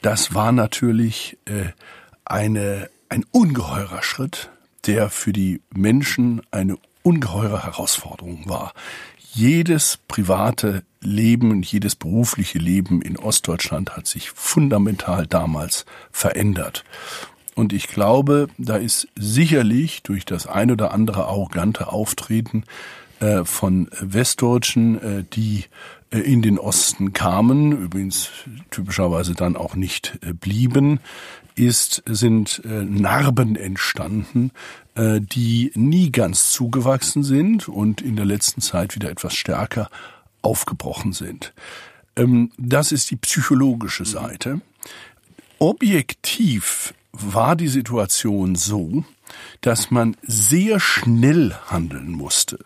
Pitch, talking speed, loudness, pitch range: 110 Hz, 100 wpm, -19 LUFS, 95-125 Hz